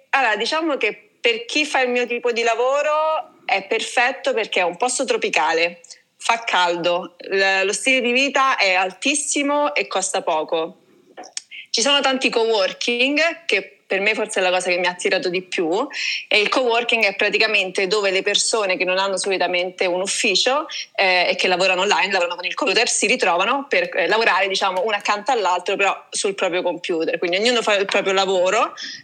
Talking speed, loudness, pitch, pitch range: 180 wpm, -19 LUFS, 210 Hz, 185-270 Hz